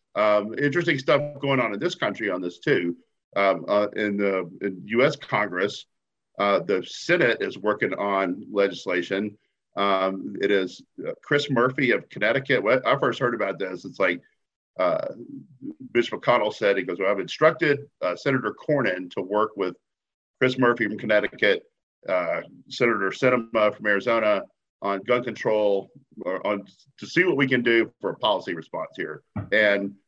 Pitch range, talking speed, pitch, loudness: 100-140 Hz, 165 wpm, 105 Hz, -24 LUFS